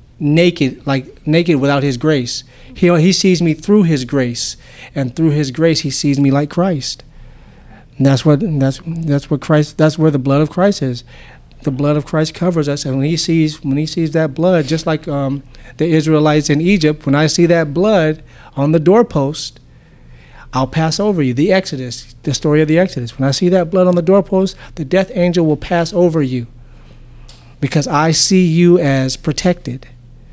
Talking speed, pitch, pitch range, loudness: 195 wpm, 150 Hz, 135-170 Hz, -14 LUFS